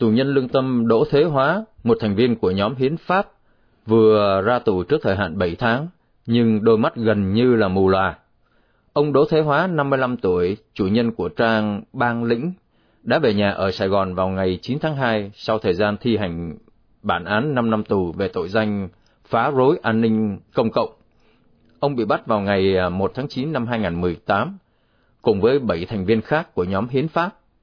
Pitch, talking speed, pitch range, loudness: 115 Hz, 200 wpm, 100-130 Hz, -20 LUFS